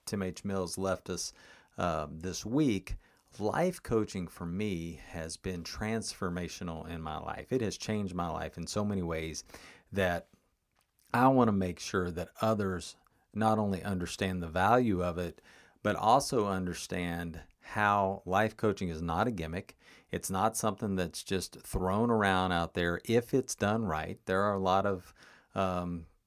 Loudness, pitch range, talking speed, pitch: -33 LUFS, 85-105 Hz, 160 wpm, 95 Hz